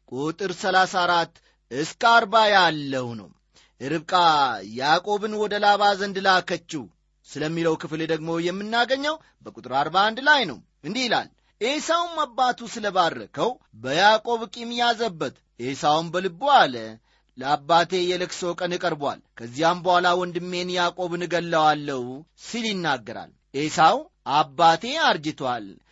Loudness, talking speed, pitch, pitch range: -22 LUFS, 110 wpm, 180 Hz, 160-220 Hz